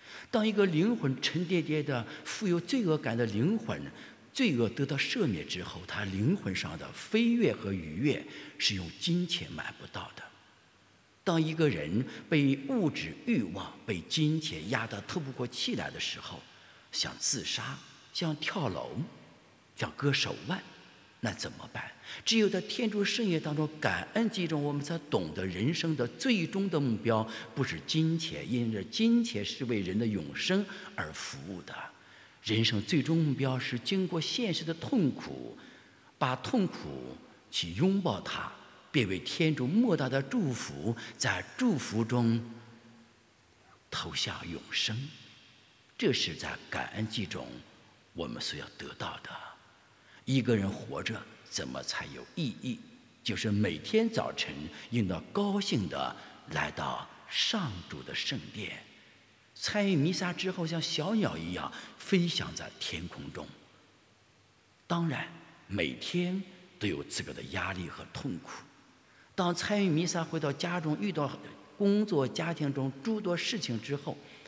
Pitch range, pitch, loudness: 115-180 Hz, 150 Hz, -32 LUFS